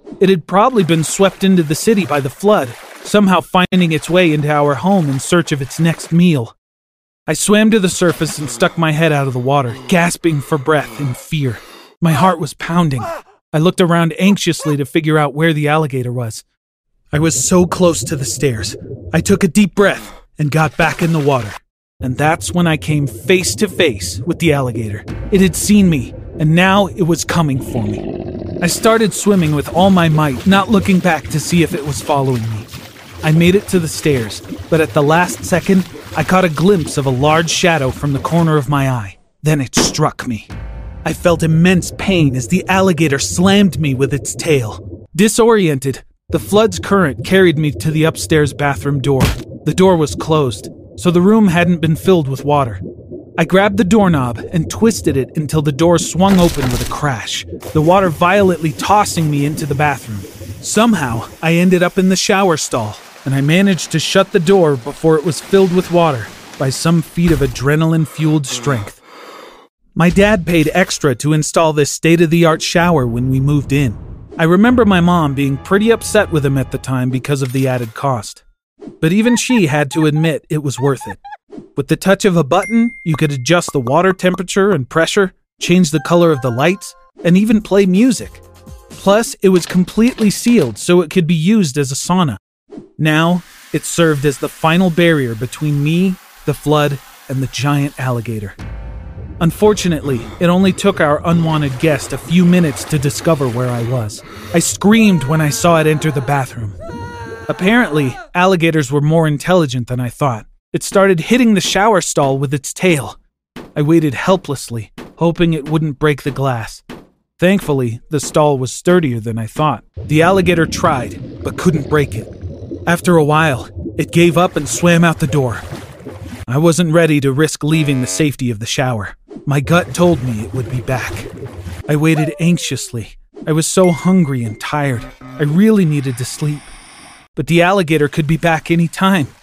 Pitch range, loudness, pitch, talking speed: 135-180 Hz, -14 LUFS, 155 Hz, 190 wpm